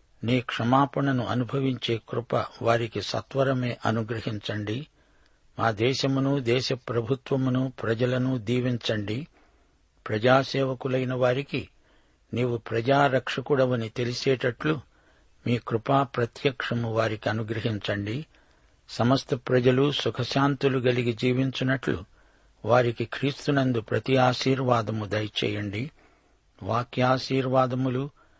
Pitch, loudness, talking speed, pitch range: 125 Hz, -26 LUFS, 70 wpm, 115-135 Hz